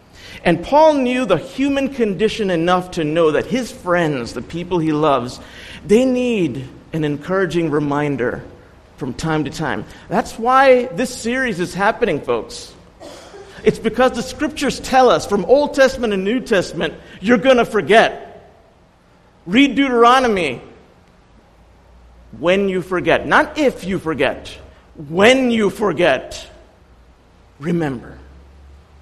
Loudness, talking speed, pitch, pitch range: -17 LUFS, 125 wpm, 195 Hz, 155-250 Hz